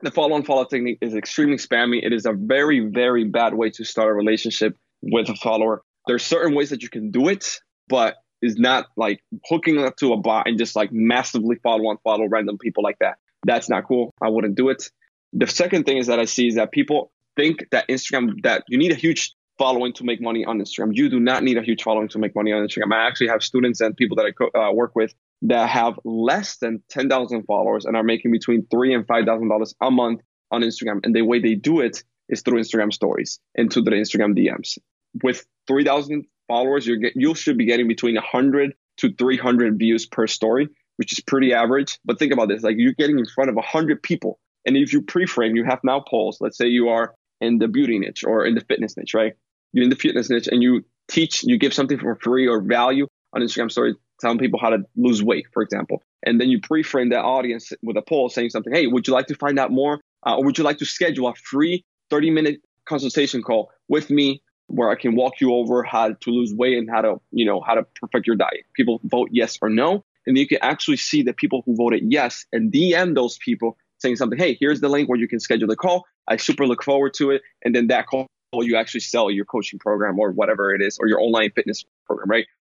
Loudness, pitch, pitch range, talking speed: -20 LUFS, 120 Hz, 115-140 Hz, 235 wpm